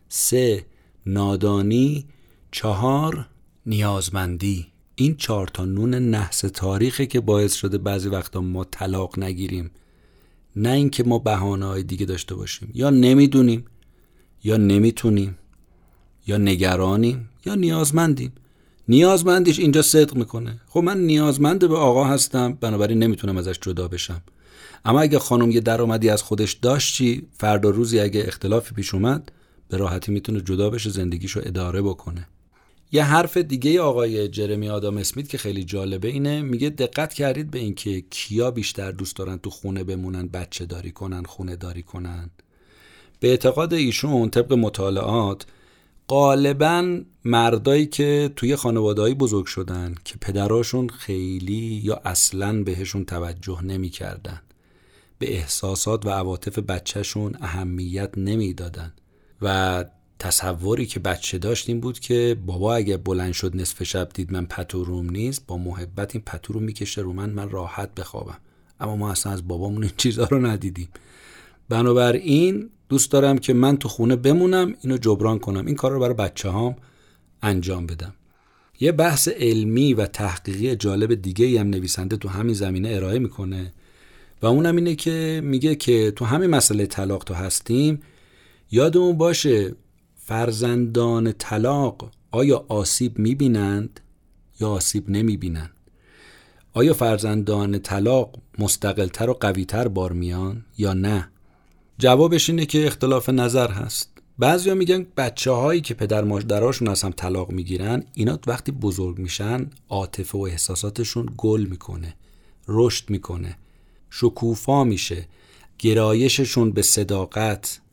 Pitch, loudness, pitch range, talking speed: 105 Hz, -21 LUFS, 95-125 Hz, 135 wpm